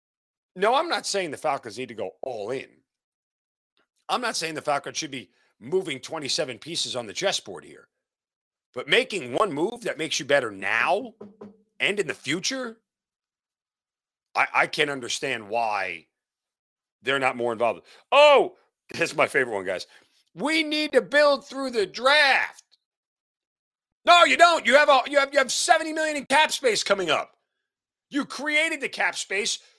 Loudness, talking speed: -23 LUFS, 170 wpm